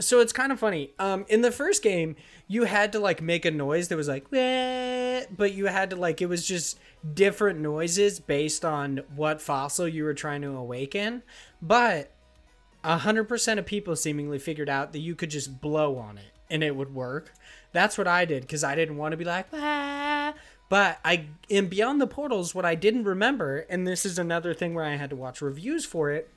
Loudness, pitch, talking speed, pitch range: -27 LUFS, 170 Hz, 215 wpm, 150-210 Hz